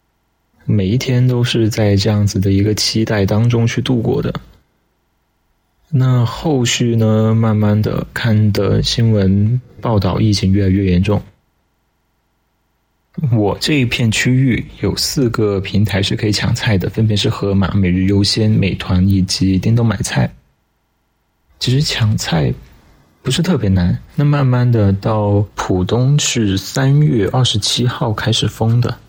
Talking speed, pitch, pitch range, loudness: 210 characters per minute, 105 Hz, 95-120 Hz, -15 LUFS